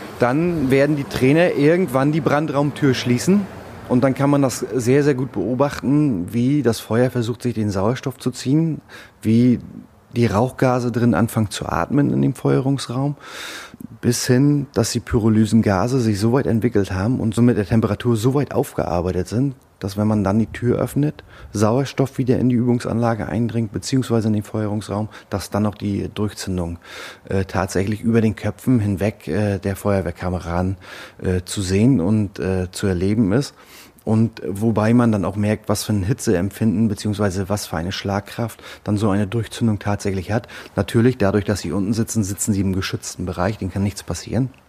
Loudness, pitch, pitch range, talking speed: -20 LUFS, 115 Hz, 100-125 Hz, 175 wpm